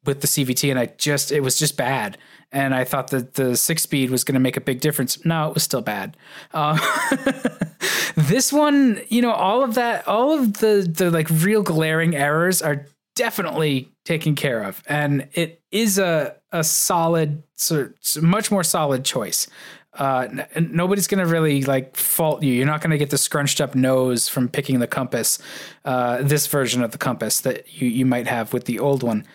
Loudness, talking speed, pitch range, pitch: -20 LUFS, 200 wpm, 135-170 Hz, 150 Hz